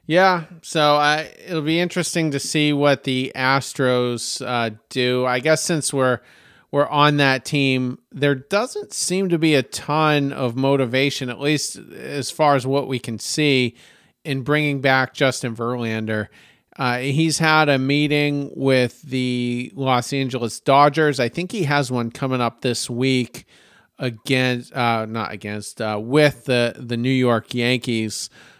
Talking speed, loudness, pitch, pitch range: 155 wpm, -20 LUFS, 135 Hz, 125-145 Hz